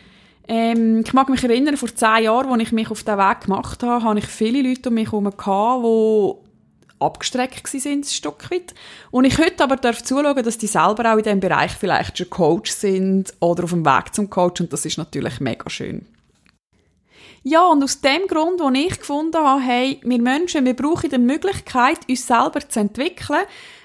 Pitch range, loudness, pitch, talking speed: 220-285 Hz, -19 LUFS, 245 Hz, 190 wpm